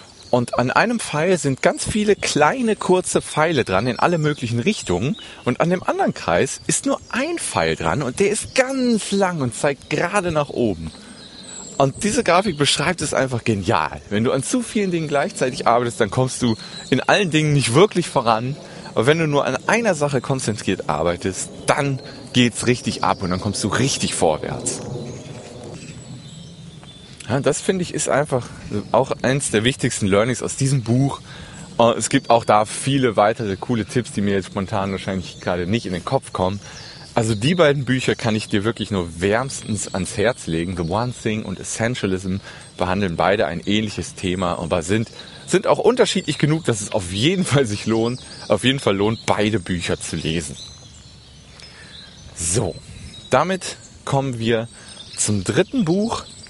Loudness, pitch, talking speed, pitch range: -20 LUFS, 125 Hz, 175 wpm, 105-150 Hz